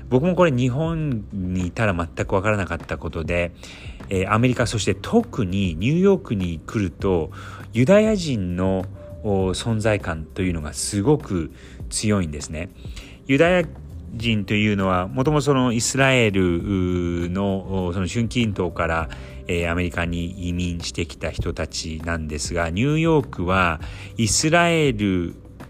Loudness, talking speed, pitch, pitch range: -22 LUFS, 290 characters per minute, 95 Hz, 85-115 Hz